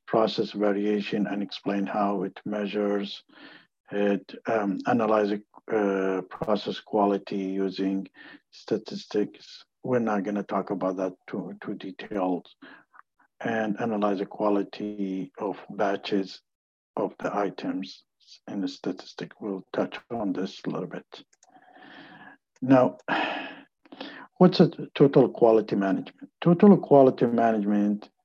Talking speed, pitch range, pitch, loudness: 115 wpm, 100-110 Hz, 105 Hz, -26 LUFS